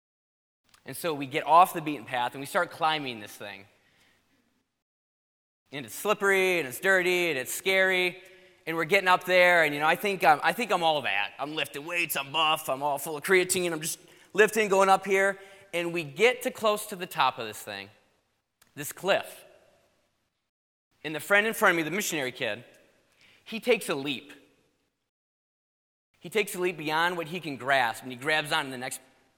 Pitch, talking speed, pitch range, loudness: 170 Hz, 200 wpm, 145-190 Hz, -26 LUFS